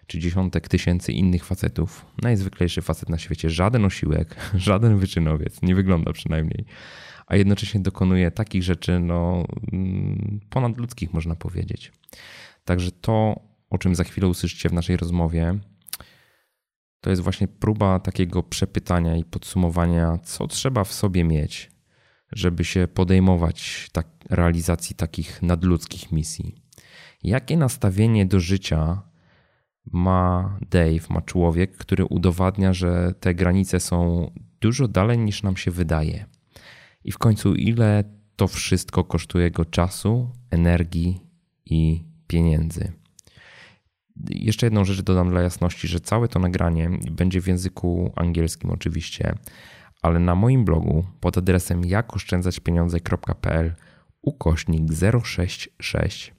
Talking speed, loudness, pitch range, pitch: 120 wpm, -22 LUFS, 85-100 Hz, 90 Hz